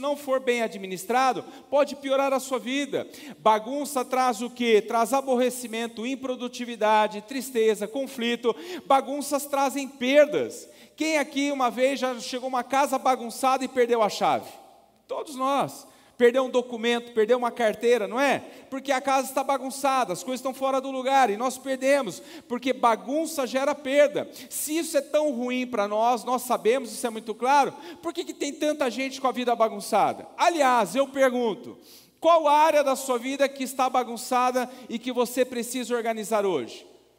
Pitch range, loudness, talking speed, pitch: 240-275 Hz, -25 LUFS, 165 wpm, 260 Hz